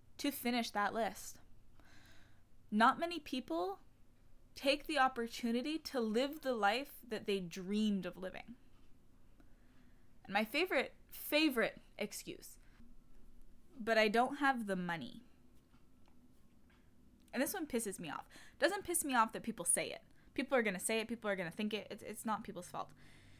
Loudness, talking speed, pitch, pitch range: -37 LUFS, 160 wpm, 230 Hz, 200-275 Hz